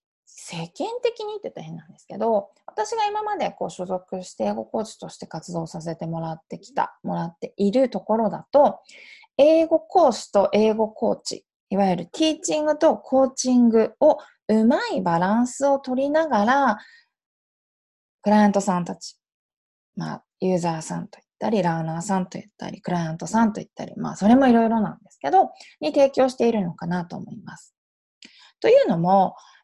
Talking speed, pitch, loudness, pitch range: 360 characters per minute, 220 Hz, -22 LUFS, 185-280 Hz